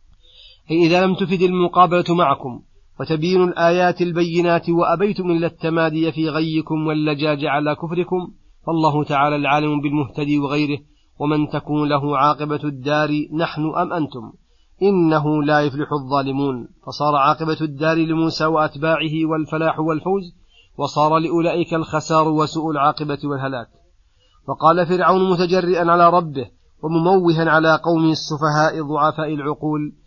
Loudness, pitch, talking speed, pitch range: -18 LUFS, 155 Hz, 115 wpm, 150-170 Hz